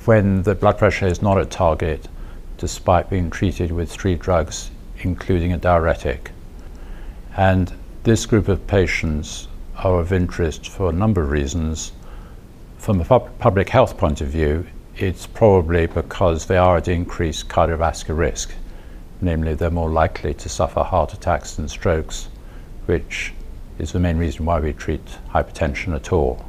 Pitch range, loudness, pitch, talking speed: 80-95 Hz, -20 LUFS, 85 Hz, 155 wpm